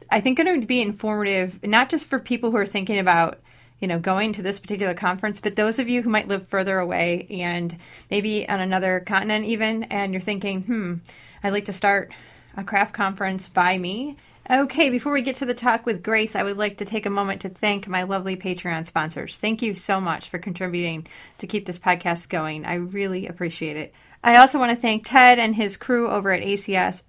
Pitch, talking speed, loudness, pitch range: 200 Hz, 215 wpm, -22 LUFS, 185-220 Hz